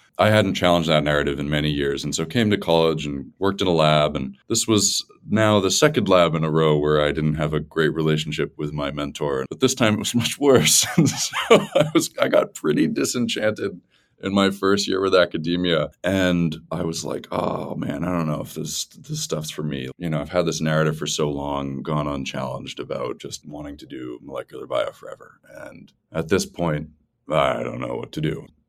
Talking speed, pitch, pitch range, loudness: 220 wpm, 80 Hz, 75-95 Hz, -21 LUFS